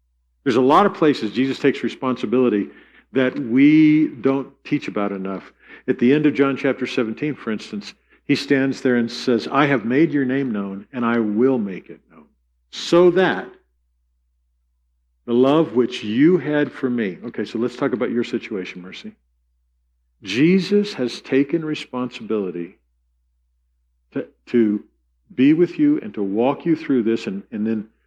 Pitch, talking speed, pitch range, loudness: 120 Hz, 160 wpm, 90-140 Hz, -20 LUFS